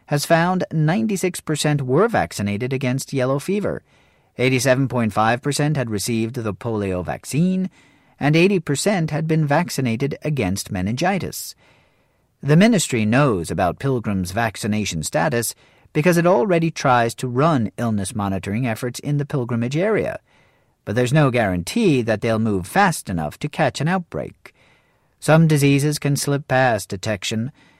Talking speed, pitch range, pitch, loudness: 130 wpm, 115-155 Hz, 130 Hz, -20 LUFS